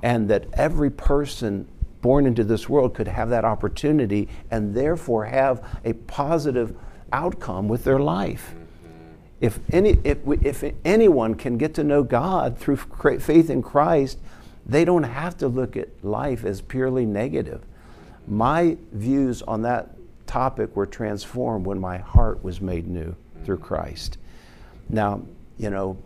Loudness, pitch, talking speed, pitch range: -23 LUFS, 115 Hz, 145 wpm, 100-135 Hz